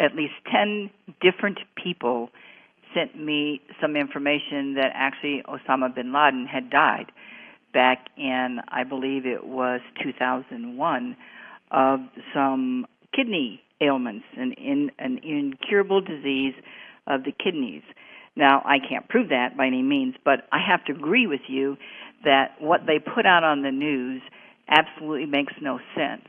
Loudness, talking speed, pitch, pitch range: -24 LUFS, 140 wpm, 145 Hz, 130-195 Hz